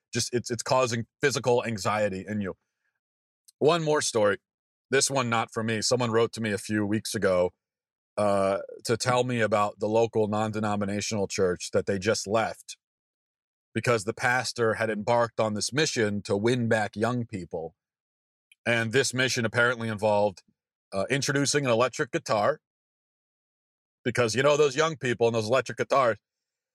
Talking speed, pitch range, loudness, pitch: 155 wpm, 105-125 Hz, -26 LUFS, 115 Hz